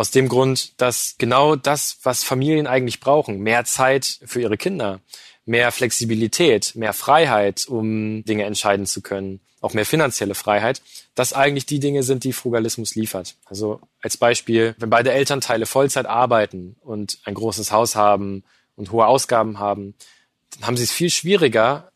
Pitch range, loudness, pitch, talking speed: 105-130 Hz, -19 LUFS, 115 Hz, 160 wpm